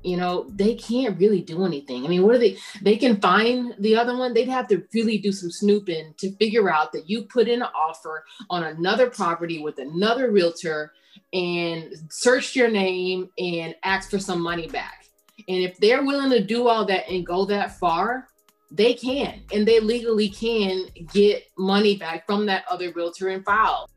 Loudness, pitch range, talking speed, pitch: -22 LUFS, 180-230 Hz, 195 wpm, 200 Hz